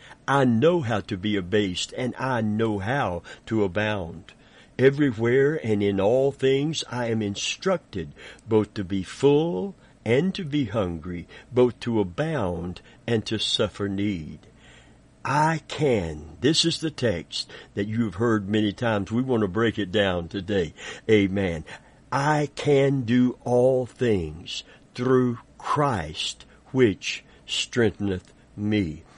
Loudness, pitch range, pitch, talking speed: -24 LUFS, 100-130 Hz, 110 Hz, 135 wpm